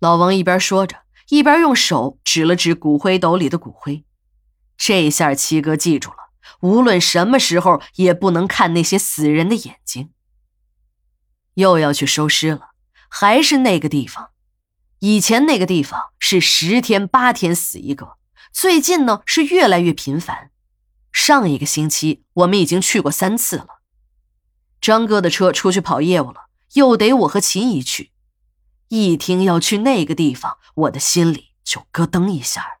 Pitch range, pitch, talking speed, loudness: 155-210 Hz, 180 Hz, 230 characters per minute, -15 LUFS